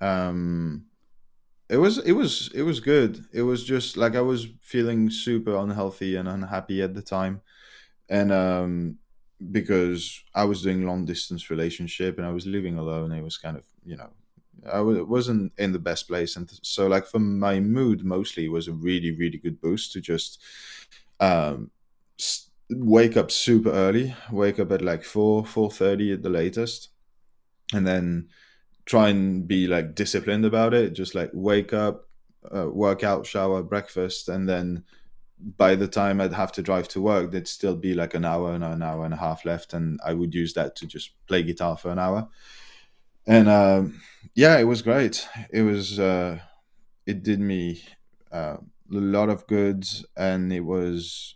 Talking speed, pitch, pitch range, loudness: 180 wpm, 95 Hz, 85-105 Hz, -24 LUFS